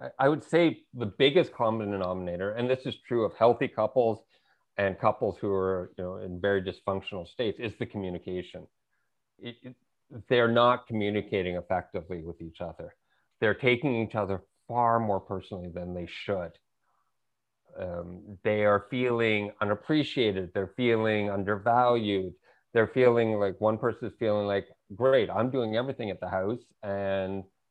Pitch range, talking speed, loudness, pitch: 95-120 Hz, 150 wpm, -28 LUFS, 105 Hz